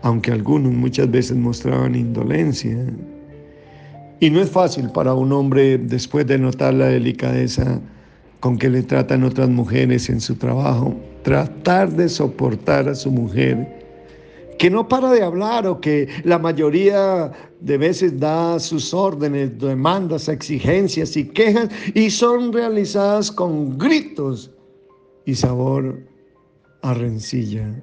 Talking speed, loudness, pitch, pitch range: 130 wpm, -18 LUFS, 140 Hz, 125-175 Hz